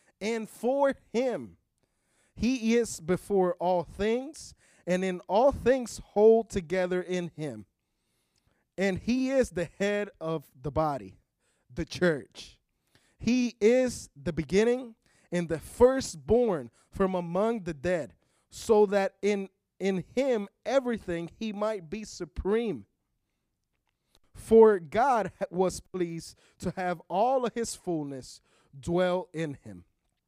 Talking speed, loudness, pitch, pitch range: 120 wpm, -28 LUFS, 190 Hz, 170-225 Hz